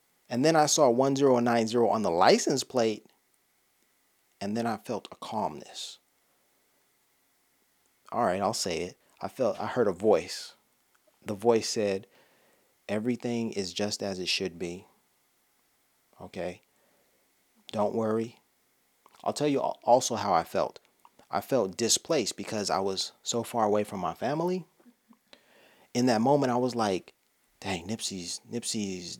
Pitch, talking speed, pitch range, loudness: 115 Hz, 140 wpm, 100-125 Hz, -28 LUFS